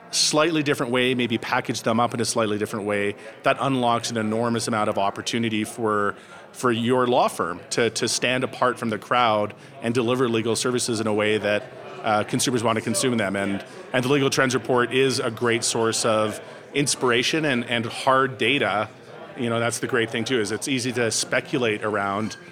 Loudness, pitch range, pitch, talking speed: -23 LUFS, 110-130 Hz, 120 Hz, 195 wpm